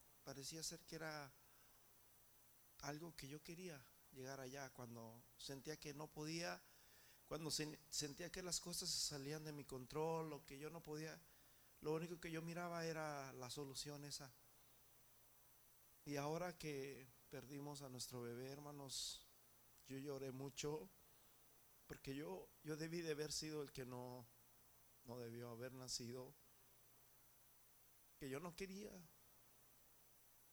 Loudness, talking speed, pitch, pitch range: -51 LUFS, 135 wpm, 145 Hz, 130-155 Hz